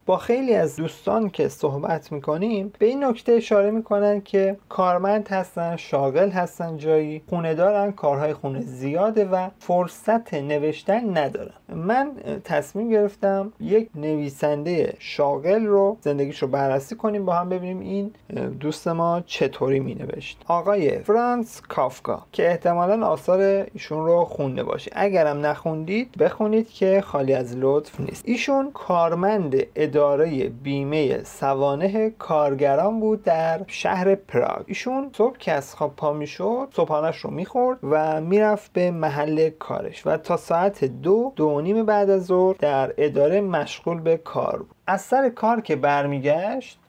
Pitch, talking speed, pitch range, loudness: 180 Hz, 140 wpm, 150-210 Hz, -23 LUFS